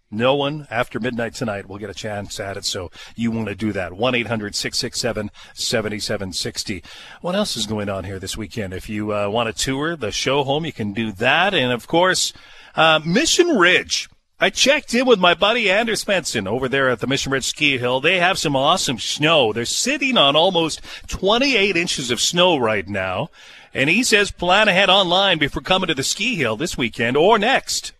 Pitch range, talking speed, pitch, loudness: 110-175 Hz, 200 wpm, 130 Hz, -18 LUFS